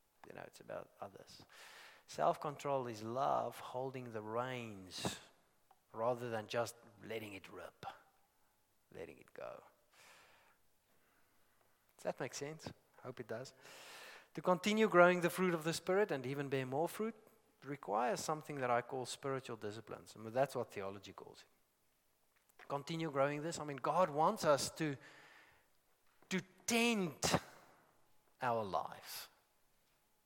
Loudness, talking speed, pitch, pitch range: -39 LUFS, 135 wpm, 140 Hz, 120-175 Hz